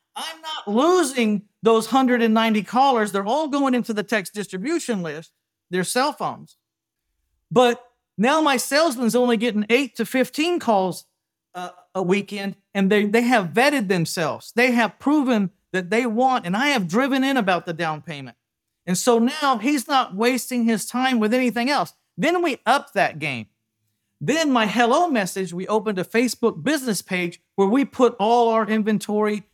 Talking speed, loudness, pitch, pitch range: 170 wpm, -21 LUFS, 225 Hz, 190-255 Hz